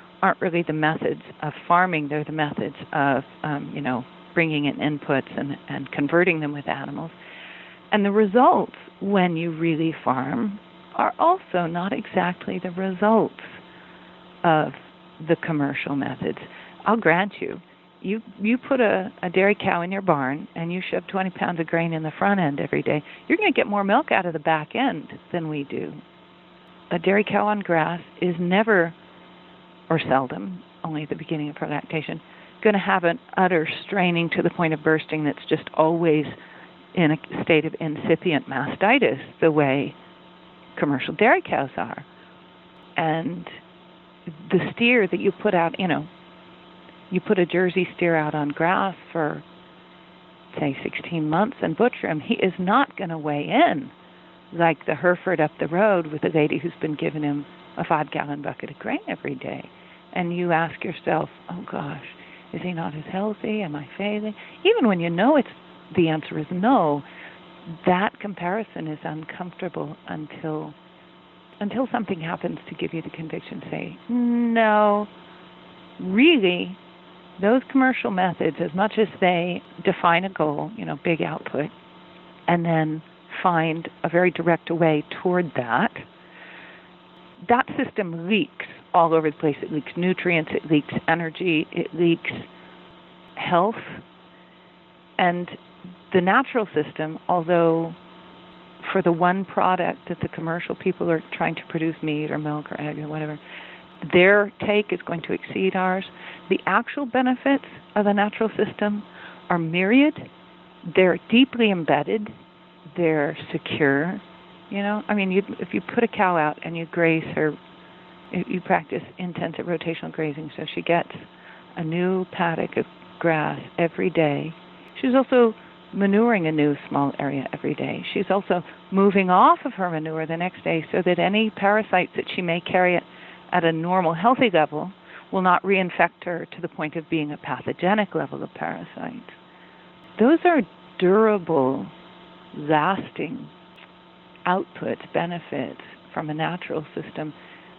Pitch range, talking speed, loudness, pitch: 160-195 Hz, 155 wpm, -23 LUFS, 175 Hz